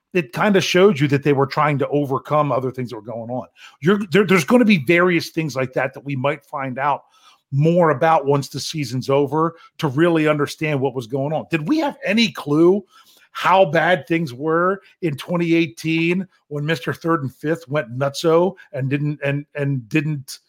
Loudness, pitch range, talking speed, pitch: -19 LUFS, 140-170 Hz, 200 wpm, 155 Hz